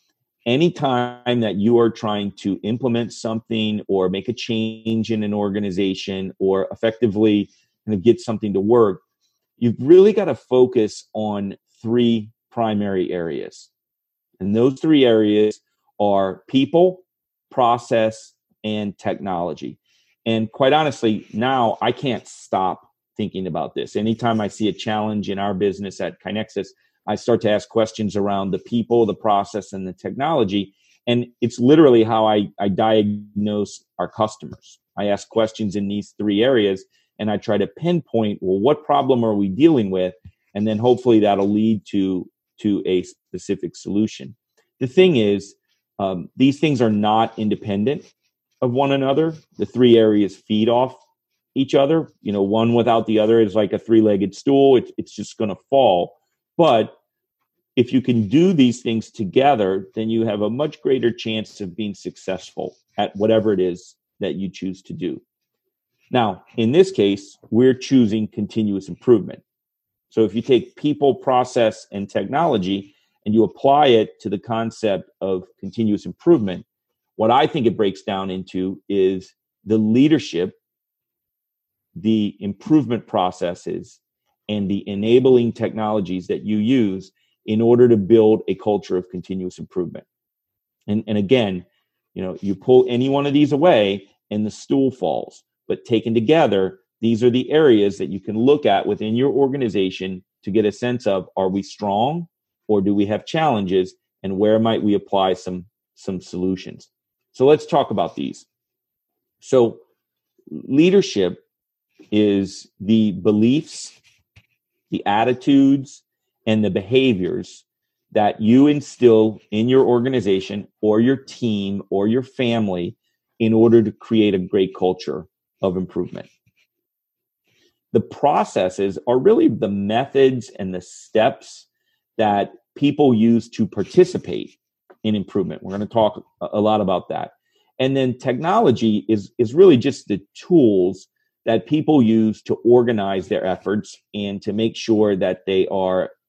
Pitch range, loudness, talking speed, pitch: 100-120 Hz, -19 LUFS, 150 wpm, 110 Hz